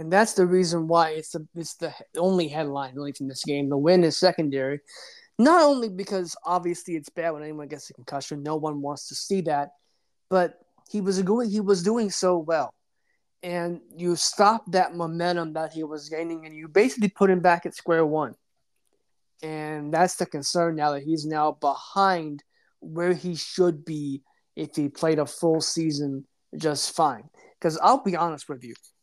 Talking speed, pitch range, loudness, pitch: 185 wpm, 150-180 Hz, -25 LUFS, 165 Hz